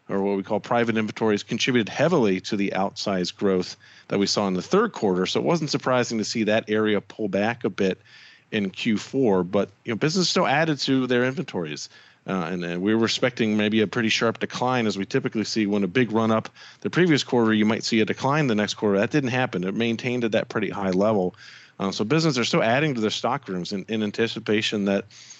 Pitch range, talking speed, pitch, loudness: 100-125 Hz, 225 wpm, 110 Hz, -23 LUFS